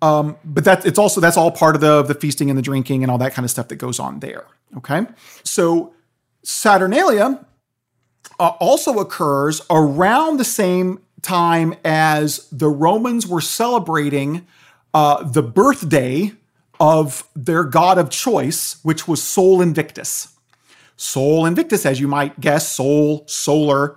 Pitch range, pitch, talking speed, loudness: 145-175 Hz, 155 Hz, 150 wpm, -16 LUFS